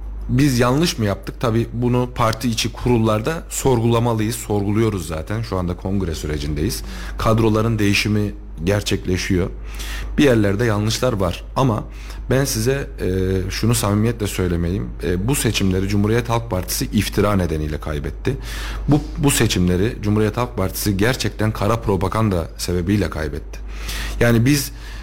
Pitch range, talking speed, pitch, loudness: 95-120 Hz, 120 wpm, 105 Hz, -20 LUFS